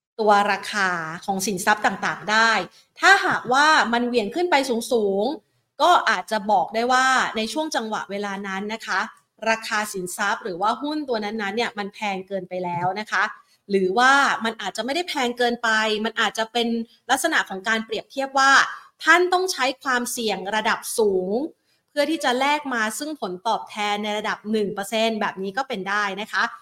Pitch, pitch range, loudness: 220 Hz, 205-255 Hz, -22 LUFS